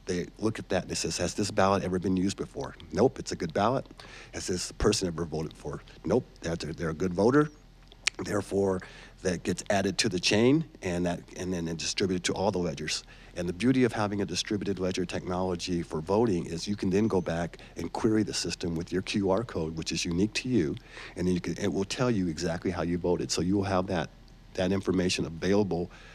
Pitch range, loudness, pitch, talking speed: 85-100 Hz, -29 LUFS, 95 Hz, 220 wpm